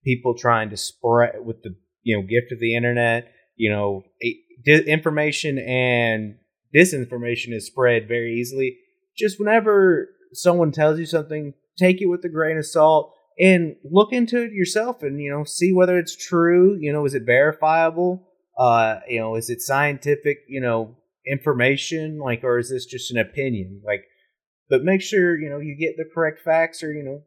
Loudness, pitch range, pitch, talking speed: -20 LUFS, 120-170 Hz, 145 Hz, 180 wpm